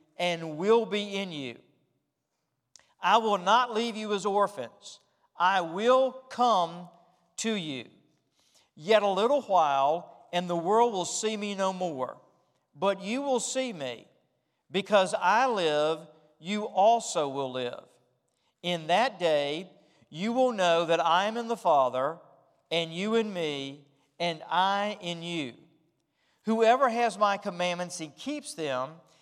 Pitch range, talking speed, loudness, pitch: 160-220 Hz, 140 wpm, -28 LUFS, 185 Hz